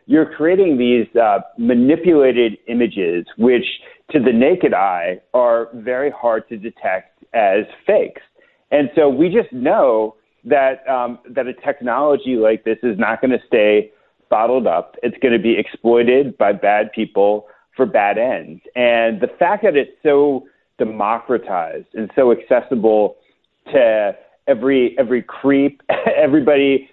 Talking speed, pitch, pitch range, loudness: 140 wpm, 120 Hz, 110-140 Hz, -16 LUFS